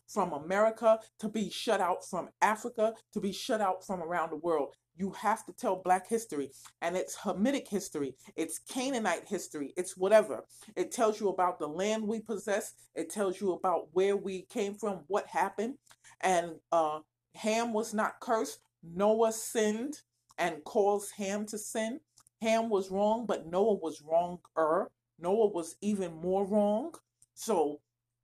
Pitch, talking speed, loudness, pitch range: 195 Hz, 160 wpm, -32 LUFS, 170-220 Hz